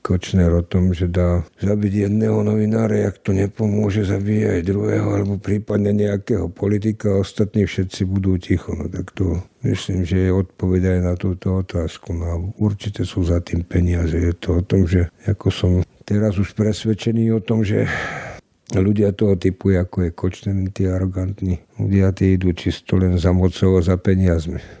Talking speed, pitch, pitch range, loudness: 170 wpm, 95 Hz, 90-105 Hz, -20 LUFS